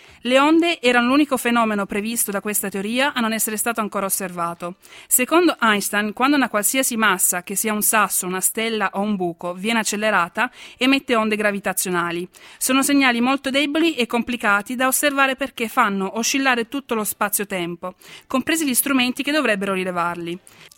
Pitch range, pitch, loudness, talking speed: 200-260 Hz, 225 Hz, -19 LUFS, 160 wpm